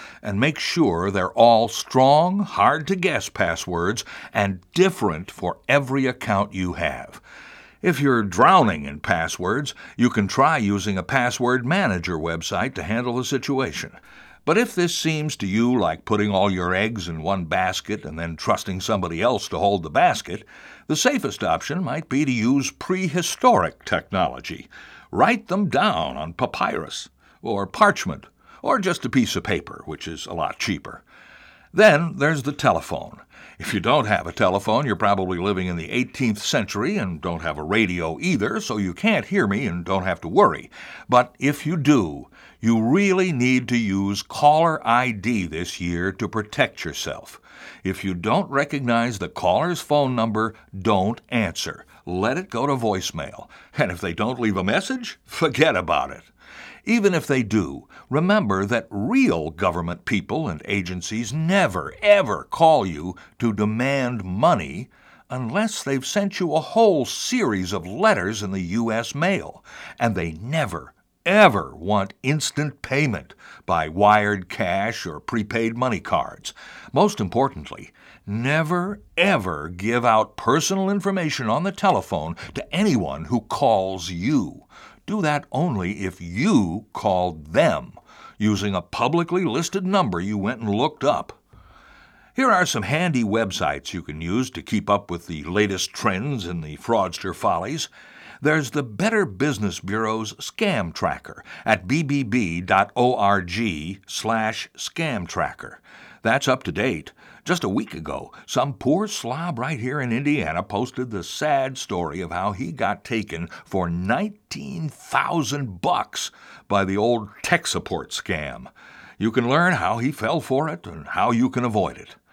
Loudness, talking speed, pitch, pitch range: -22 LUFS, 155 wpm, 115 Hz, 100-150 Hz